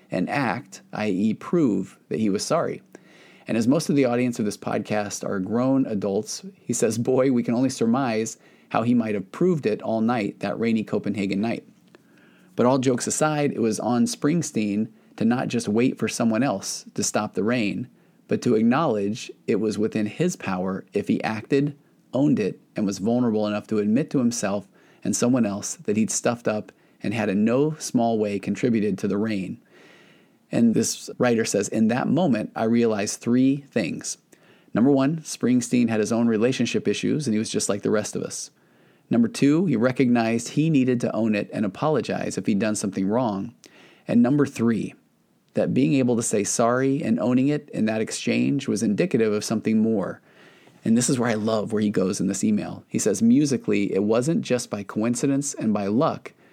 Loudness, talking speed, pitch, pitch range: -23 LUFS, 195 wpm, 115 Hz, 110-135 Hz